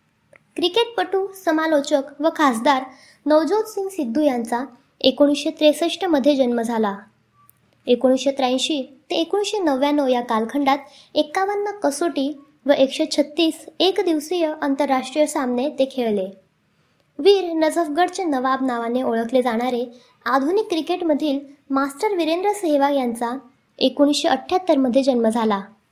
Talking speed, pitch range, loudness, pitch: 115 wpm, 255-325 Hz, -20 LUFS, 285 Hz